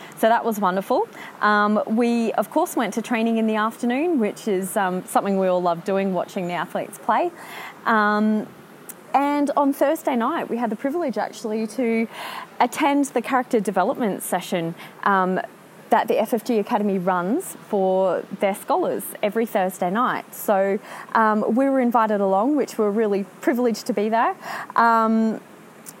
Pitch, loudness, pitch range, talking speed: 220 Hz, -22 LUFS, 200-250 Hz, 160 wpm